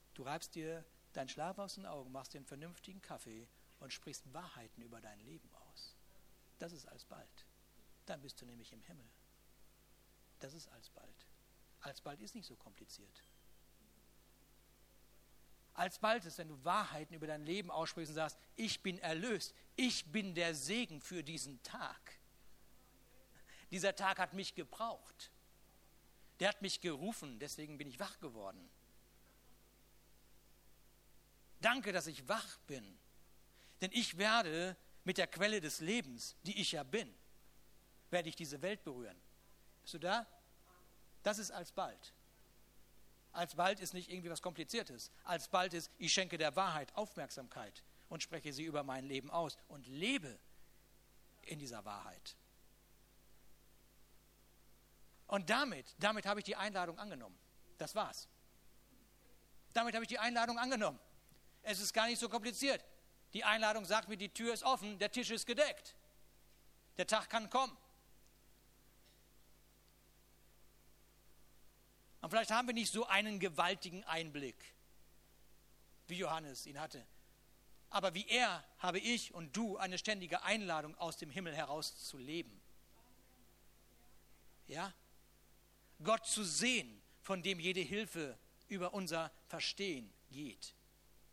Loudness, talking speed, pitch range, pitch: -41 LUFS, 135 wpm, 155-210 Hz, 180 Hz